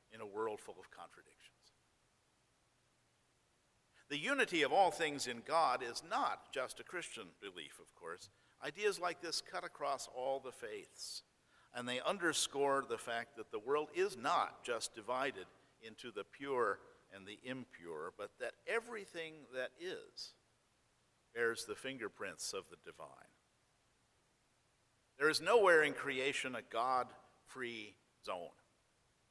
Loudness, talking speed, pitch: -39 LUFS, 135 wpm, 135 Hz